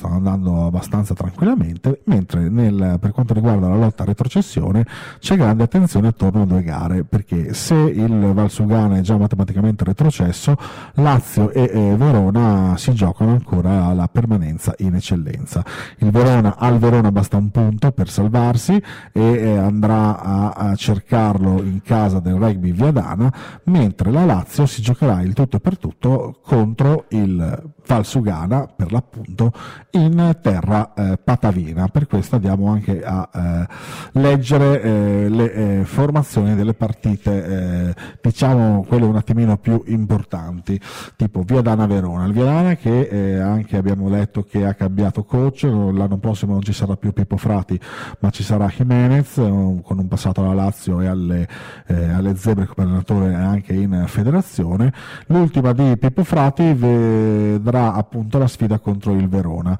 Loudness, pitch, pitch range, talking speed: -17 LUFS, 105 Hz, 95-125 Hz, 150 wpm